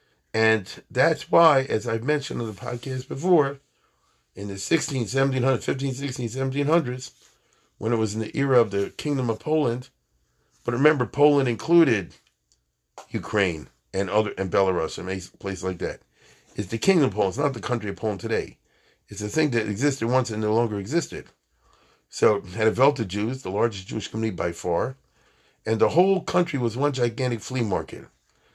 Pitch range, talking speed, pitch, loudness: 105-140 Hz, 175 wpm, 115 Hz, -24 LUFS